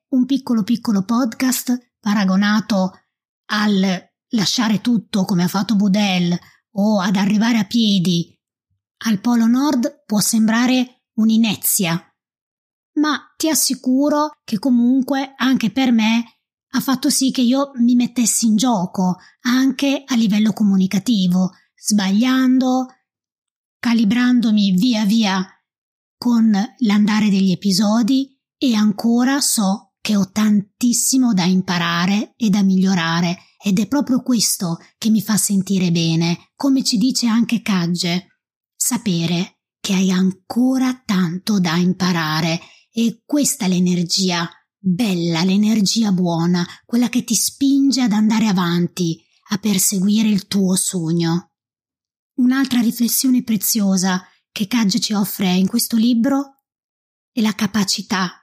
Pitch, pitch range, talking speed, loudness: 215 Hz, 190-245 Hz, 120 wpm, -17 LUFS